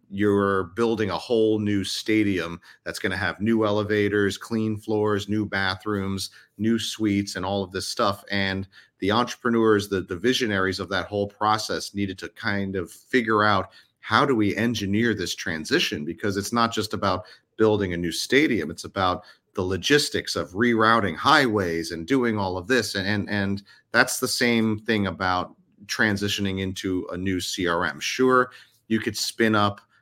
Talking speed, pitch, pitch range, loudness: 170 wpm, 105 Hz, 95-110 Hz, -24 LUFS